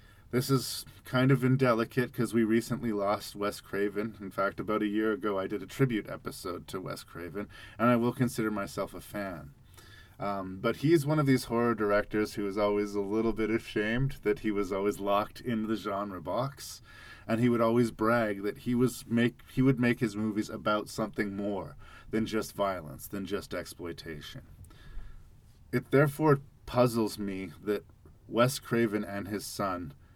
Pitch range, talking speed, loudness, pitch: 100-120 Hz, 175 wpm, -31 LUFS, 110 Hz